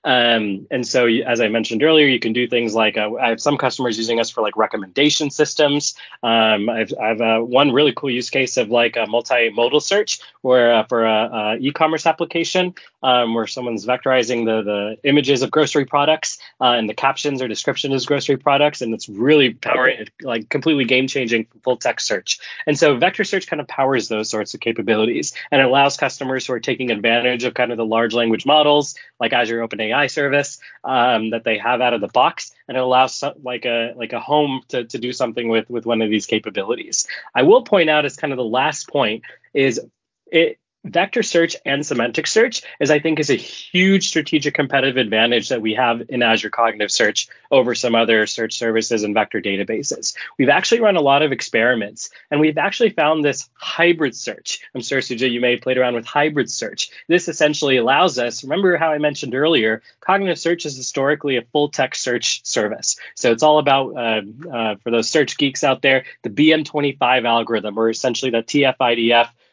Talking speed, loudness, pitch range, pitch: 200 wpm, -18 LUFS, 115-150 Hz, 125 Hz